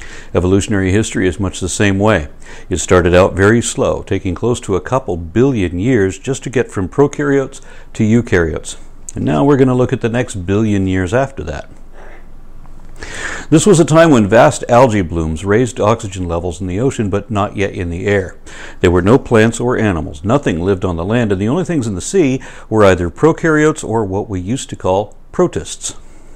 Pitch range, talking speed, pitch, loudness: 95-130 Hz, 200 wpm, 105 Hz, -14 LUFS